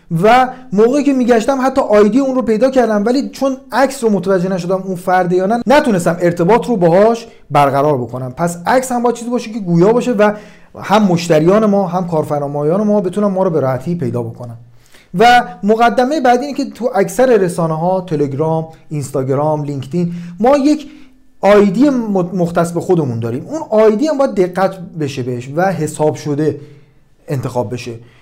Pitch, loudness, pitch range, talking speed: 190 Hz, -14 LUFS, 155-240 Hz, 170 wpm